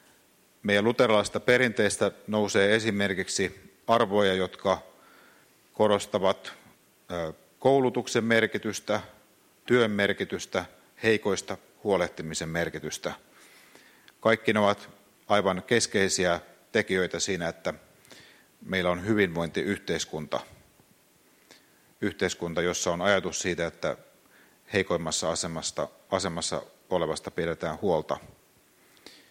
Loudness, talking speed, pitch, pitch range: -27 LUFS, 80 wpm, 100 Hz, 85-105 Hz